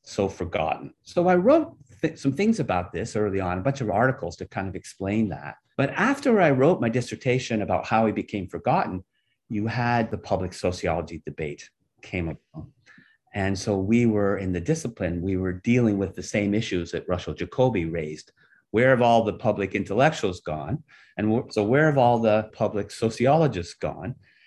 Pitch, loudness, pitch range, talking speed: 110 Hz, -24 LUFS, 95-125 Hz, 180 wpm